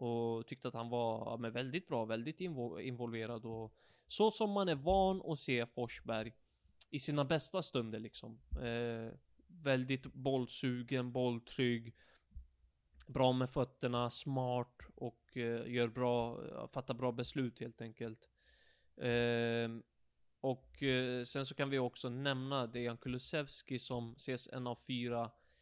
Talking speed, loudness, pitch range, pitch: 135 wpm, -39 LUFS, 115-135 Hz, 125 Hz